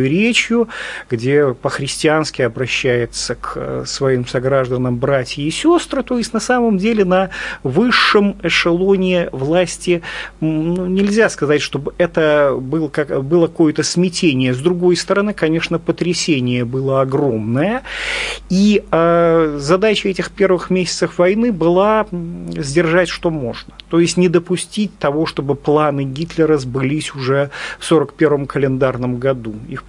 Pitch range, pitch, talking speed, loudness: 140-185 Hz, 165 Hz, 115 wpm, -16 LUFS